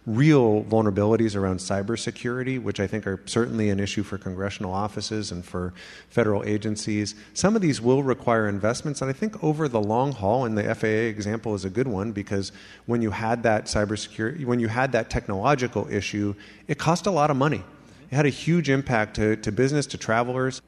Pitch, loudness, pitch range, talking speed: 110 Hz, -25 LUFS, 105-130 Hz, 195 wpm